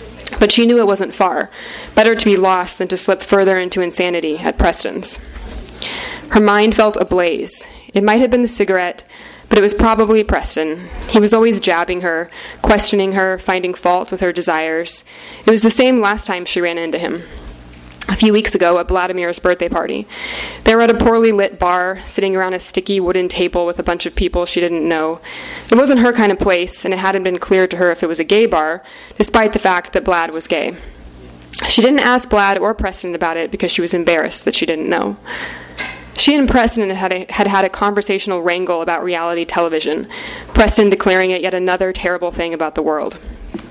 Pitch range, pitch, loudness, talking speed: 175-210 Hz, 185 Hz, -15 LUFS, 205 wpm